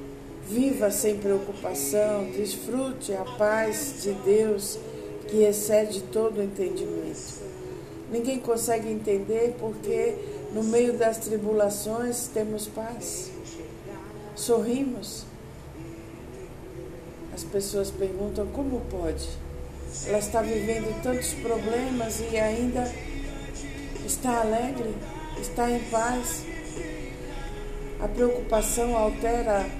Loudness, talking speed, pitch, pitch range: -28 LUFS, 90 wpm, 220 Hz, 205-240 Hz